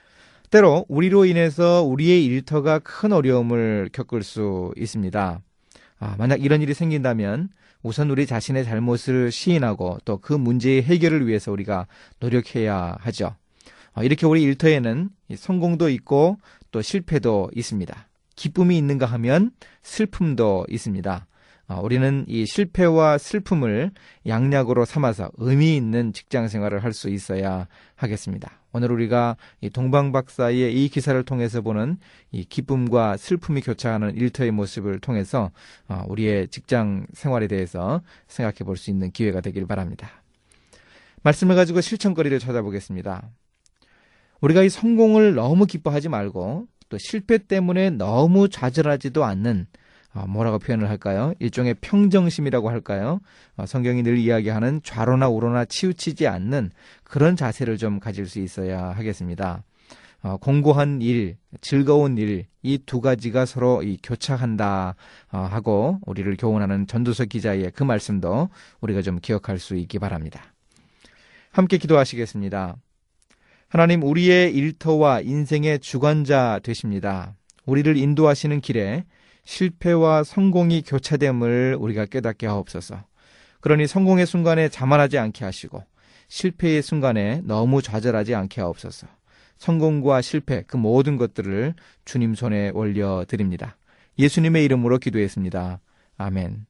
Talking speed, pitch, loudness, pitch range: 310 characters per minute, 125 Hz, -21 LUFS, 105-150 Hz